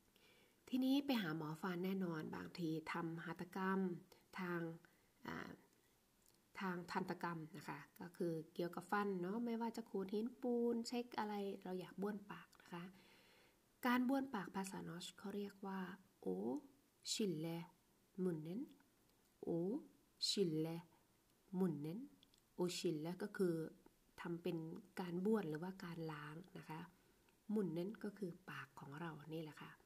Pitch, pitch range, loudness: 185 Hz, 170-205 Hz, -46 LUFS